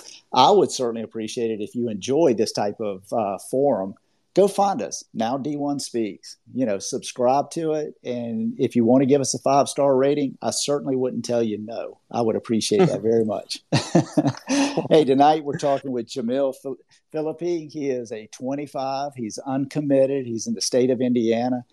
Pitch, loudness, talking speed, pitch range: 135 Hz, -22 LUFS, 180 wpm, 120-145 Hz